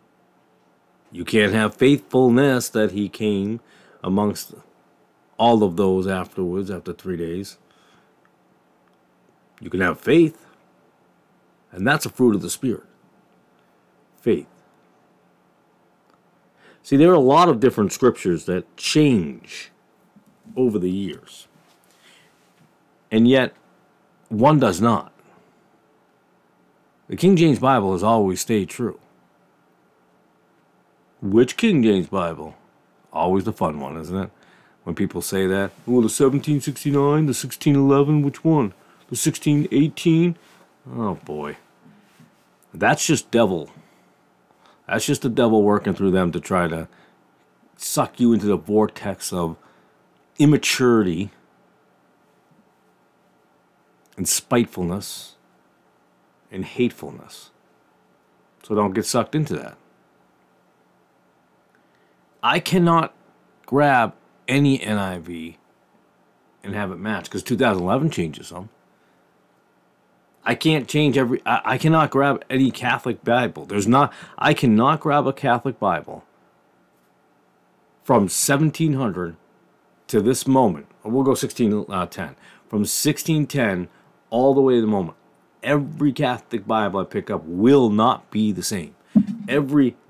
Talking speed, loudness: 115 wpm, -20 LUFS